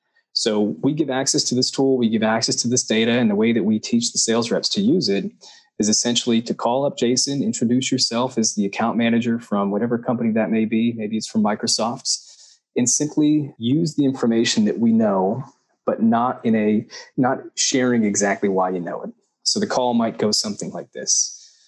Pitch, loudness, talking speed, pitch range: 120 Hz, -20 LUFS, 205 wpm, 110-140 Hz